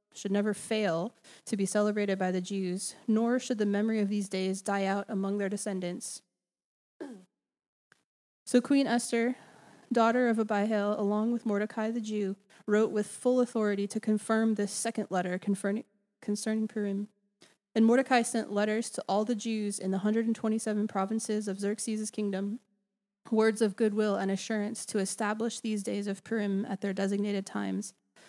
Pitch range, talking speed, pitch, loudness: 200-225 Hz, 160 wpm, 210 Hz, -31 LUFS